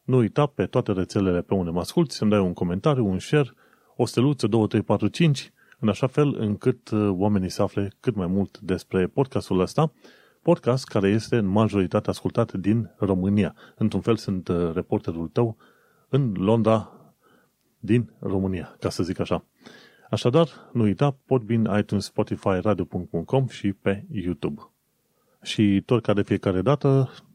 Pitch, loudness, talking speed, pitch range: 105 Hz, -24 LUFS, 160 wpm, 95-125 Hz